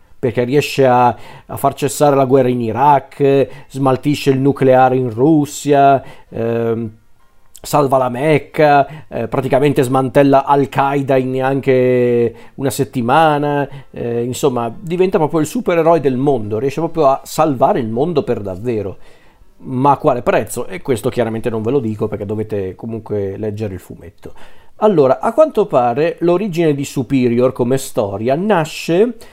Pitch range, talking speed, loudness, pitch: 120-145 Hz, 145 wpm, -15 LUFS, 135 Hz